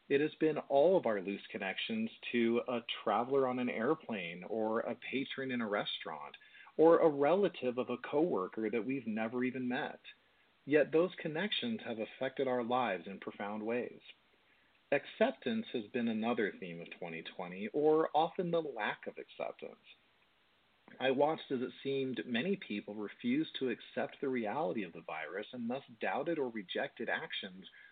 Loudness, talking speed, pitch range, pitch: -36 LUFS, 160 wpm, 120-170 Hz, 135 Hz